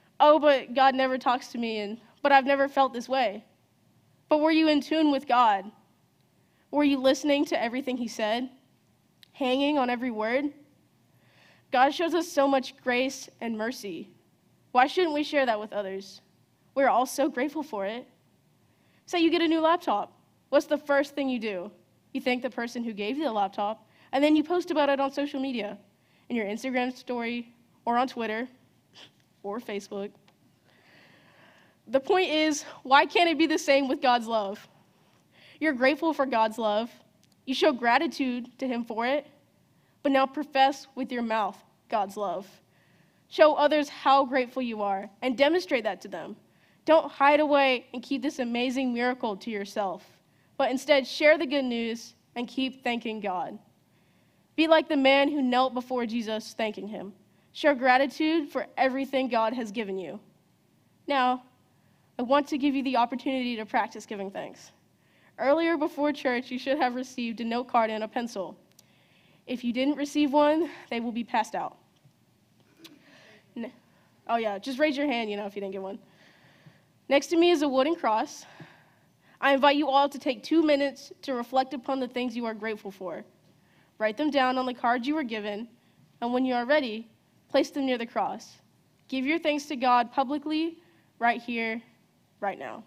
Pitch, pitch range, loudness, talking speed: 260 Hz, 230-285 Hz, -27 LUFS, 180 wpm